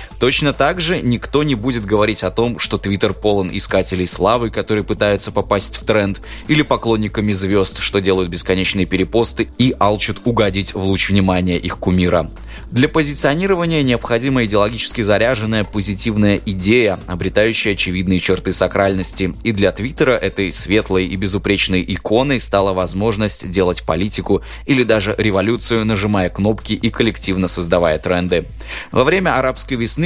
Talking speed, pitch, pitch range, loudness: 140 wpm, 100 Hz, 95-115 Hz, -16 LUFS